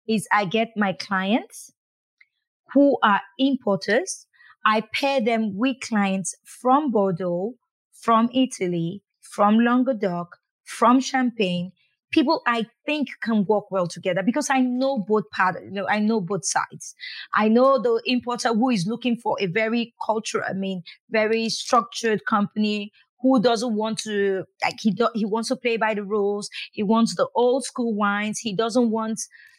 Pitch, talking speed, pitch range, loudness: 225 Hz, 160 wpm, 205-250 Hz, -23 LUFS